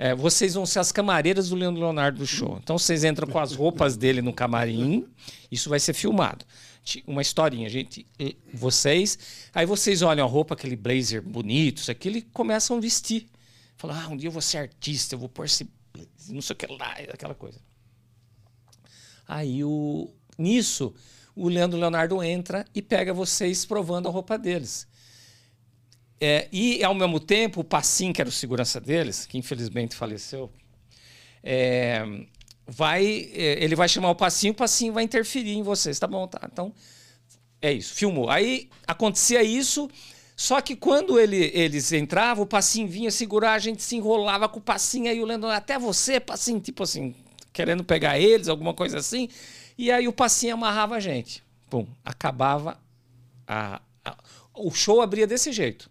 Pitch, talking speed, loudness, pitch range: 160 Hz, 175 wpm, -24 LUFS, 125-205 Hz